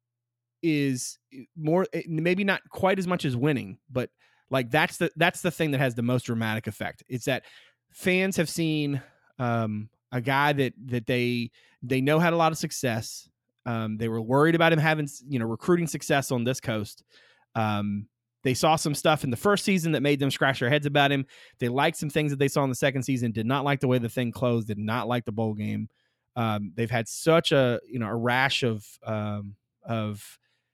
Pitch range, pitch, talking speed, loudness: 115-155 Hz, 130 Hz, 210 wpm, -26 LUFS